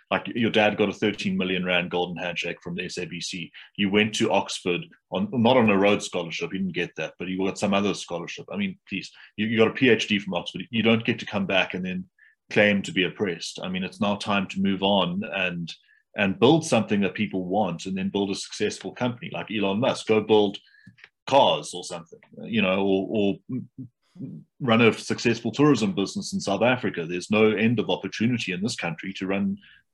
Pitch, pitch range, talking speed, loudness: 100 Hz, 95-110 Hz, 210 wpm, -24 LUFS